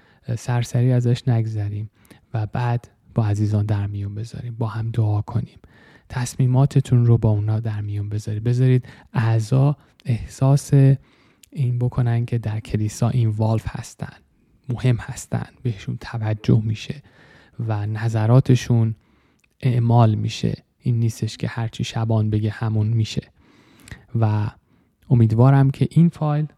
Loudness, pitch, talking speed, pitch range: -21 LUFS, 115 Hz, 125 wpm, 110-125 Hz